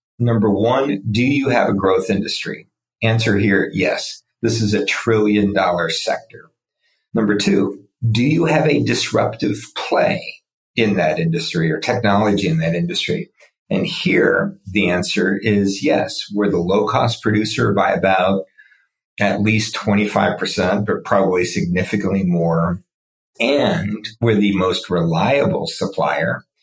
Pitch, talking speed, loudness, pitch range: 105 Hz, 135 wpm, -18 LUFS, 95-115 Hz